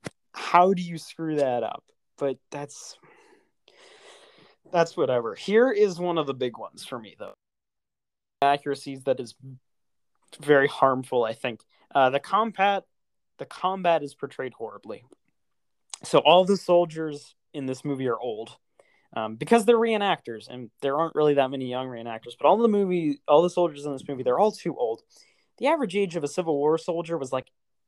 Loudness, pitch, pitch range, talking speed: -25 LUFS, 155 Hz, 135-190 Hz, 170 wpm